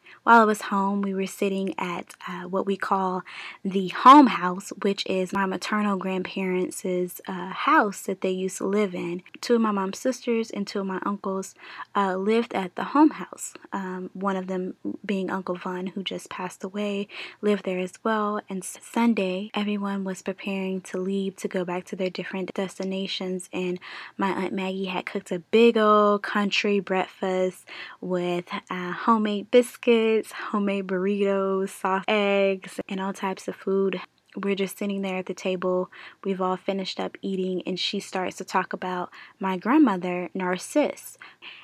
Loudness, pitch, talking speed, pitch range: -25 LUFS, 195 Hz, 170 wpm, 185-205 Hz